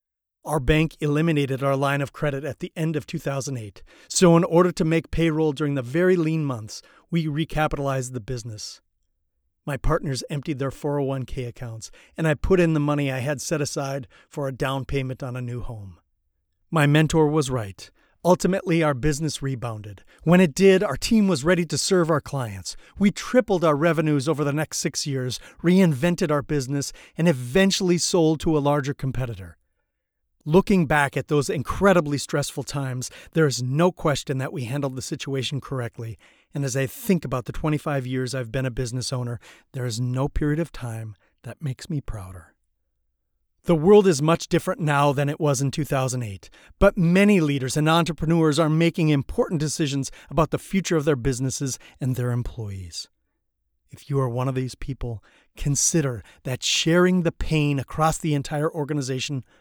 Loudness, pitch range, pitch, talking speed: -23 LUFS, 125-160 Hz, 145 Hz, 175 wpm